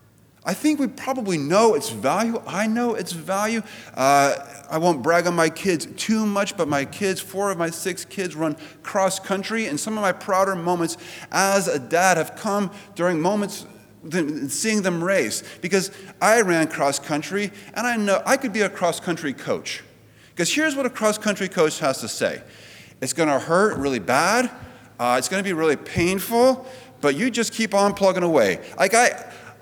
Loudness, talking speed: -22 LUFS, 195 wpm